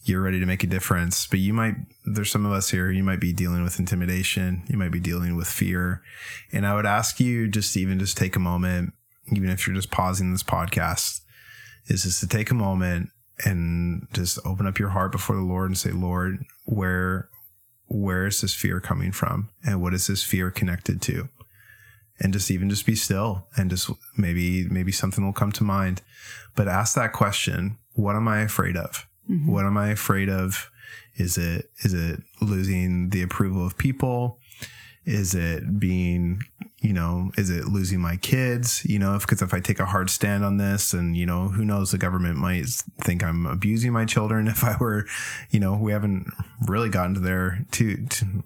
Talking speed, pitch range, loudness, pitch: 200 wpm, 90-110 Hz, -25 LUFS, 100 Hz